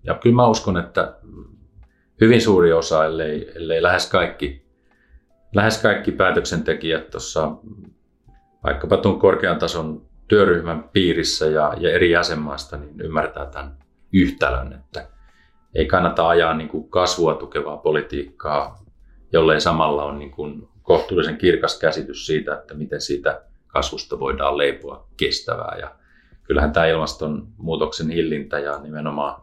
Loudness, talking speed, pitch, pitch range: -20 LUFS, 125 wpm, 75 Hz, 70-85 Hz